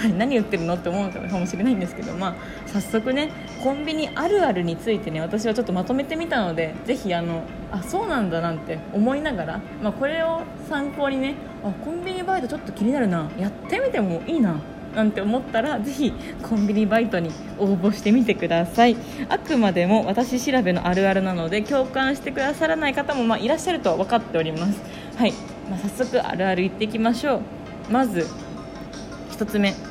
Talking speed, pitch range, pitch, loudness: 405 characters per minute, 195-270 Hz, 225 Hz, -23 LUFS